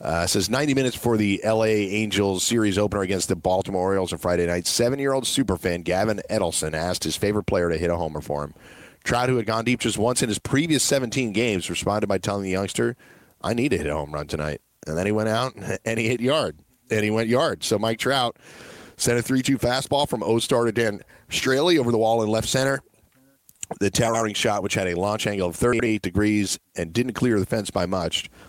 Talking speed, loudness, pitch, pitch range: 225 wpm, -23 LUFS, 105 Hz, 95-120 Hz